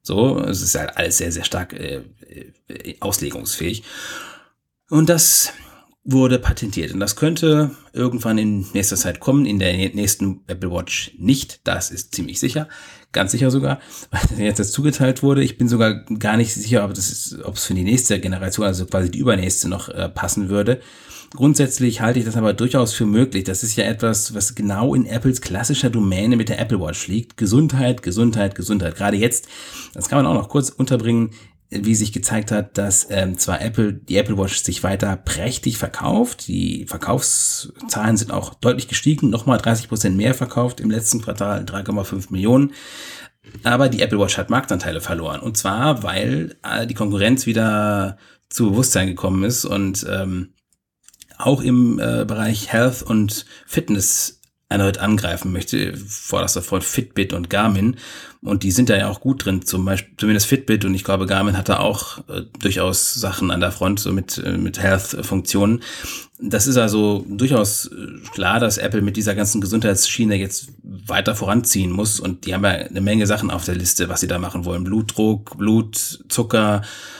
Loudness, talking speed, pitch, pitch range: -19 LUFS, 175 wpm, 105 Hz, 95-120 Hz